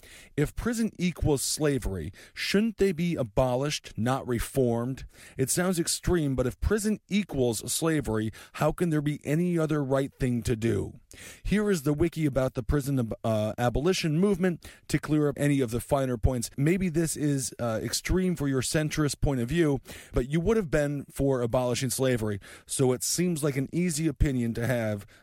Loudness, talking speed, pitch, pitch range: -28 LUFS, 180 wpm, 135 Hz, 120-160 Hz